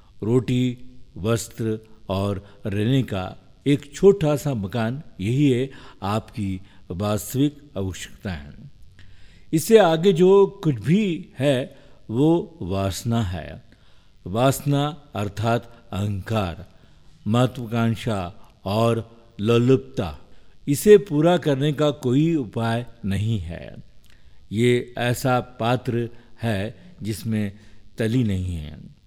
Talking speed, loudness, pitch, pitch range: 95 wpm, -22 LUFS, 115 Hz, 100-135 Hz